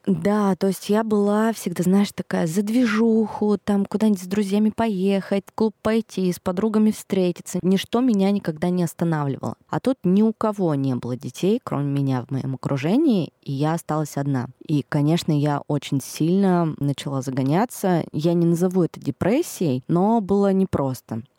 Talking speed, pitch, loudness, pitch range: 165 wpm, 185 Hz, -22 LUFS, 150-205 Hz